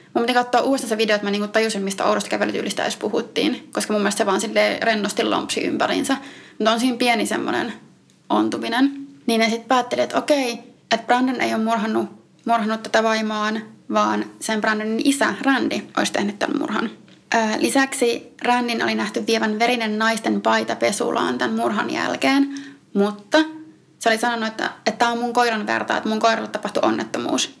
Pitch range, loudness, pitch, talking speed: 210-245 Hz, -21 LUFS, 225 Hz, 170 wpm